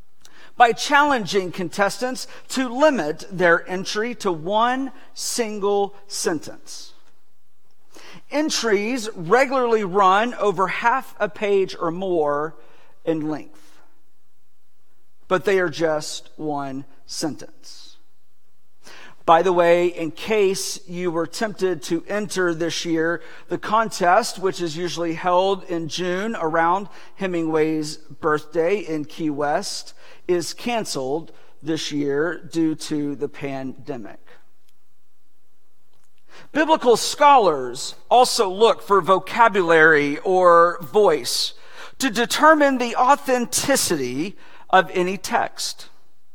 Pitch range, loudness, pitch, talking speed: 160-225 Hz, -20 LUFS, 185 Hz, 100 wpm